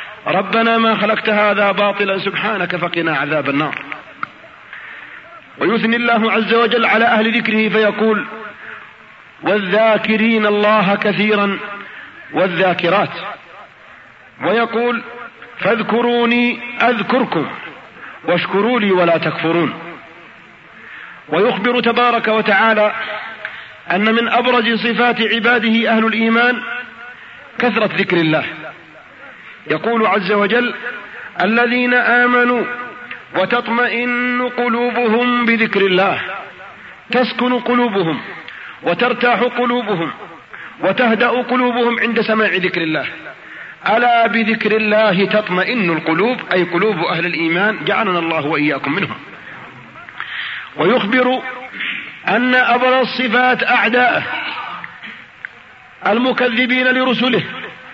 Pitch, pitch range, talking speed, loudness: 225 Hz, 200-245 Hz, 85 wpm, -15 LUFS